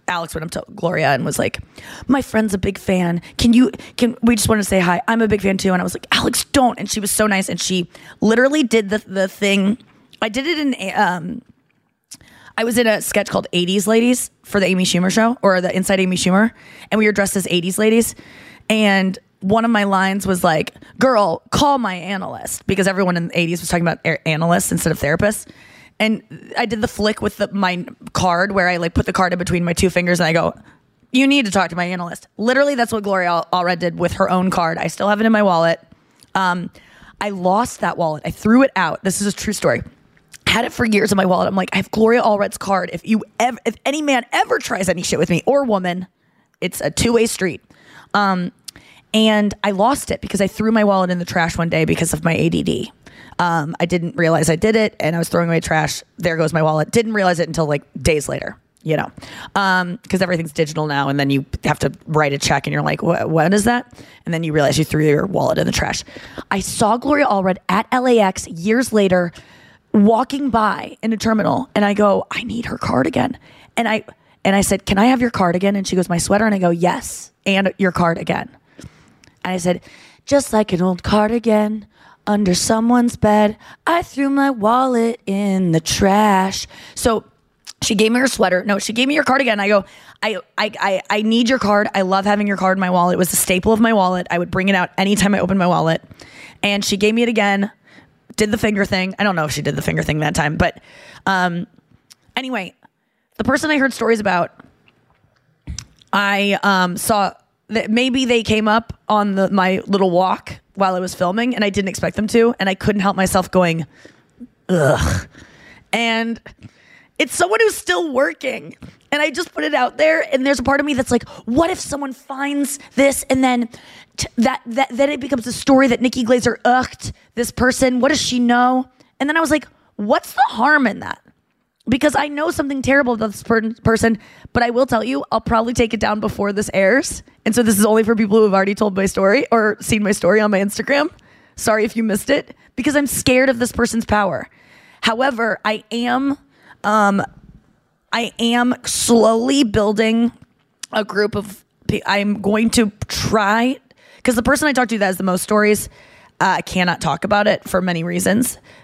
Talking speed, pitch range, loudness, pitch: 220 wpm, 185-235 Hz, -17 LUFS, 210 Hz